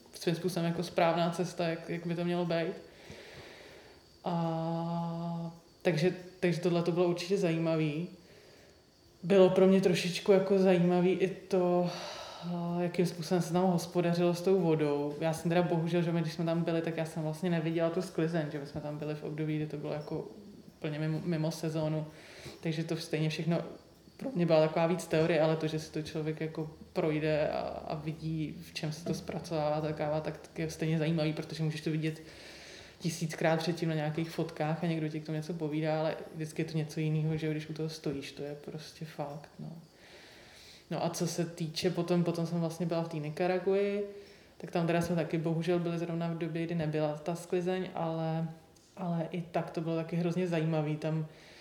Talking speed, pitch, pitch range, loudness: 195 wpm, 165 Hz, 155-175 Hz, -33 LUFS